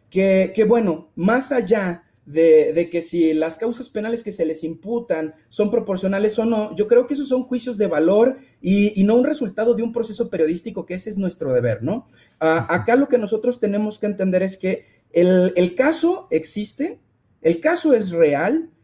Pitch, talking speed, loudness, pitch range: 210 Hz, 195 wpm, -20 LUFS, 170-235 Hz